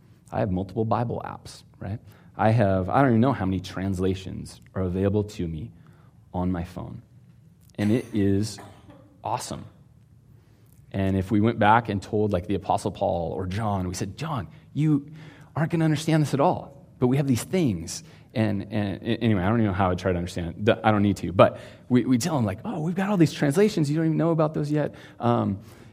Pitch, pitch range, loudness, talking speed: 110 Hz, 100-140 Hz, -25 LUFS, 210 wpm